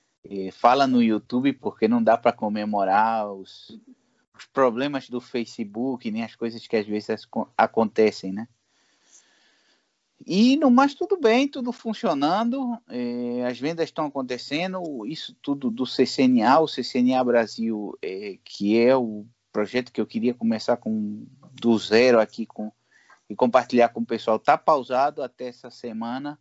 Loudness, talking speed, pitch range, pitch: -23 LUFS, 145 wpm, 115-160 Hz, 125 Hz